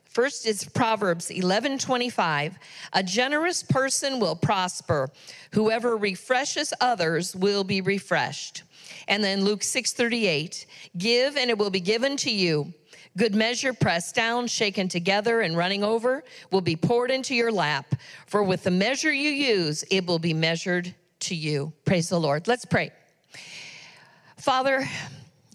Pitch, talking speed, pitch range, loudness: 200 Hz, 140 wpm, 175-240 Hz, -25 LUFS